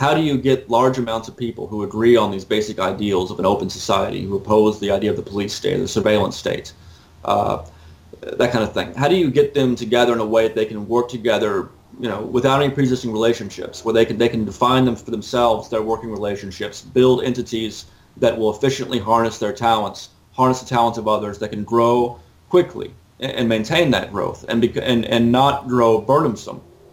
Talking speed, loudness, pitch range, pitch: 210 wpm, -19 LUFS, 105-125 Hz, 115 Hz